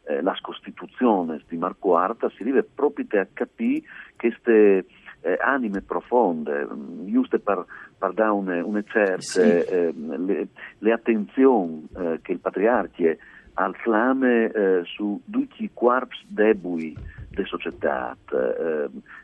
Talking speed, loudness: 125 wpm, -23 LUFS